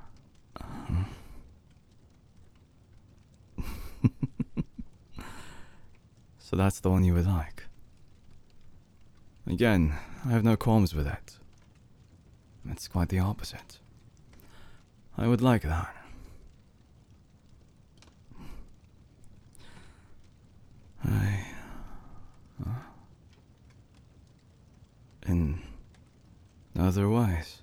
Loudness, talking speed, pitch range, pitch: -29 LUFS, 60 wpm, 85-110 Hz, 95 Hz